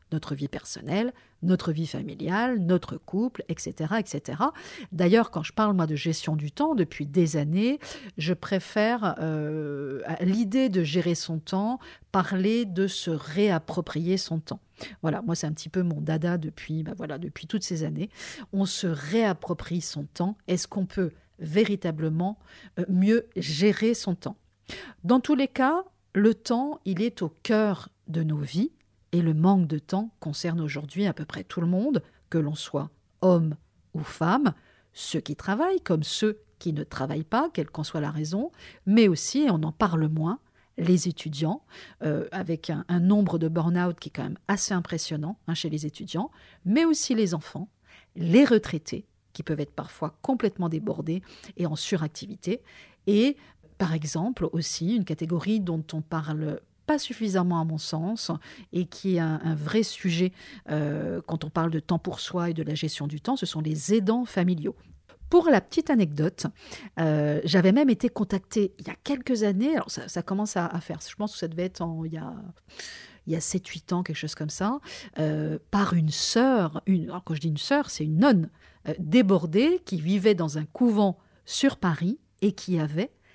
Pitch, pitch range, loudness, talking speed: 180 Hz, 160-210 Hz, -27 LUFS, 185 wpm